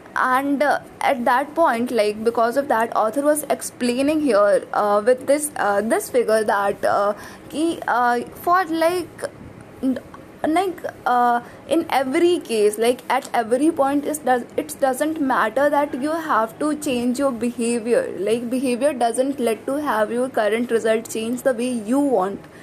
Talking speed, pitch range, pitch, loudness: 160 wpm, 235-295 Hz, 255 Hz, -20 LUFS